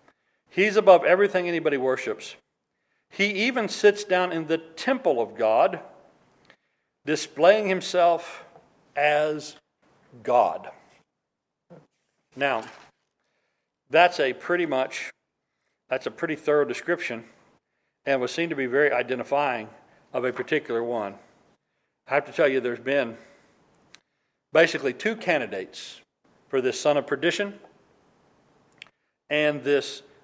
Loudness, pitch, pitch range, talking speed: -24 LUFS, 165 Hz, 145-185 Hz, 115 wpm